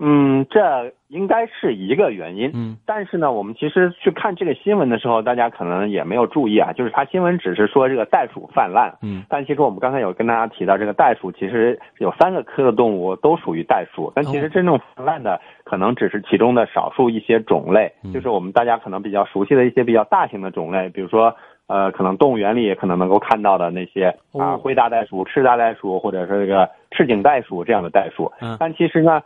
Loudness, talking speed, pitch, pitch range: -18 LUFS, 355 characters per minute, 115 Hz, 100-145 Hz